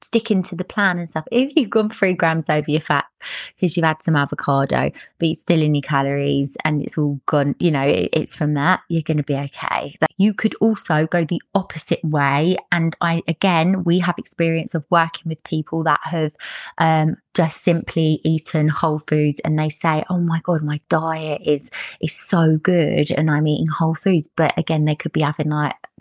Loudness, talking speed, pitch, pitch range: -19 LUFS, 205 wpm, 160 Hz, 150-175 Hz